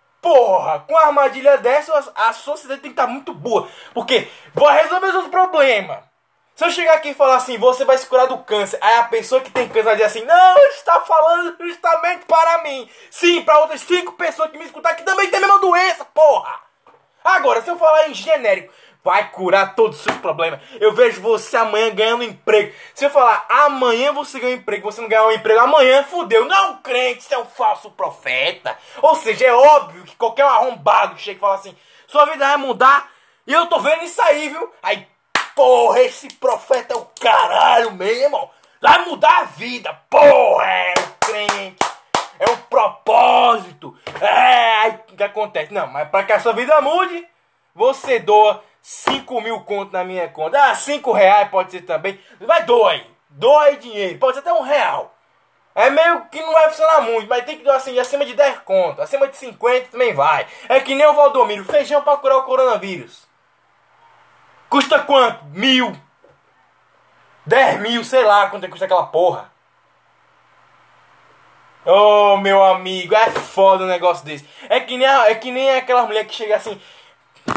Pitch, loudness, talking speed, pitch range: 275 Hz, -15 LUFS, 190 wpm, 220-315 Hz